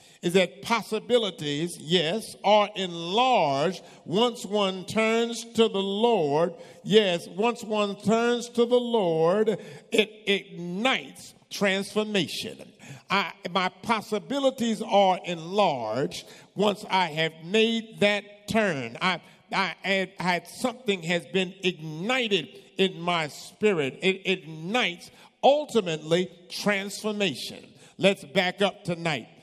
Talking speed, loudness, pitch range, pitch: 110 wpm, -26 LUFS, 180-225 Hz, 200 Hz